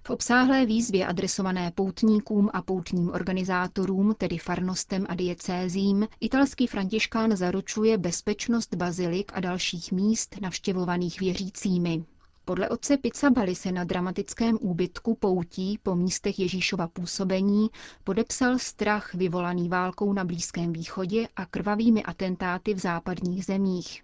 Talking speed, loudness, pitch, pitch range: 115 wpm, -27 LUFS, 190 Hz, 180-210 Hz